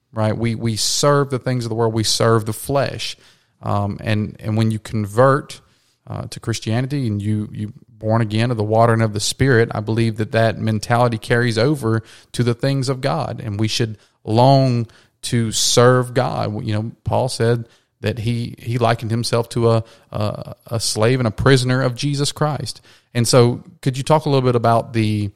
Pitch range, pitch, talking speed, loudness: 110-125 Hz, 115 Hz, 195 wpm, -18 LUFS